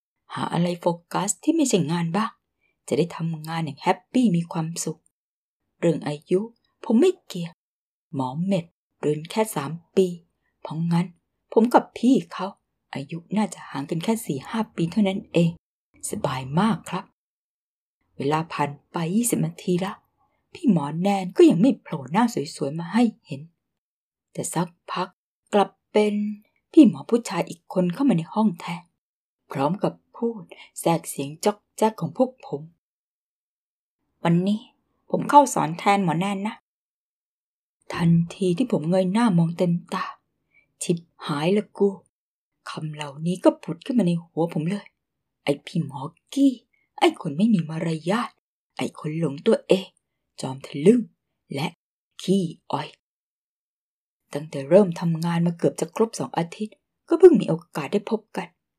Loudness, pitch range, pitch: -24 LUFS, 165-215 Hz, 180 Hz